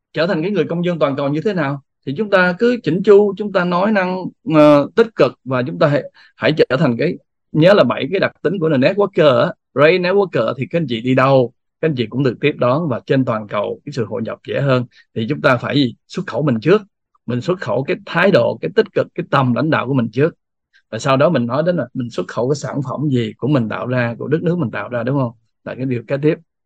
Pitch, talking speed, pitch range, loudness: 145 Hz, 275 wpm, 125-175 Hz, -17 LUFS